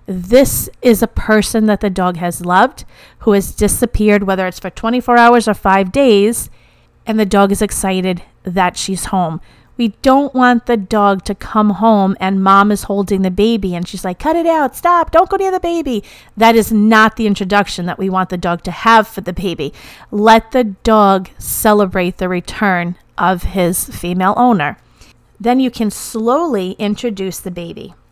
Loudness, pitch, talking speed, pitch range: -13 LUFS, 205 Hz, 185 wpm, 190-230 Hz